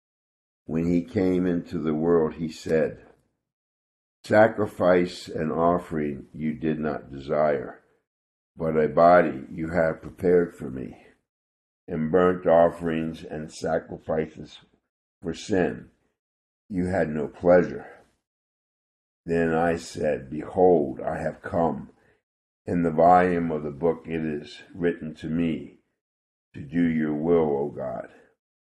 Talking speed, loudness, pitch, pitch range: 120 wpm, -24 LUFS, 80 Hz, 75-85 Hz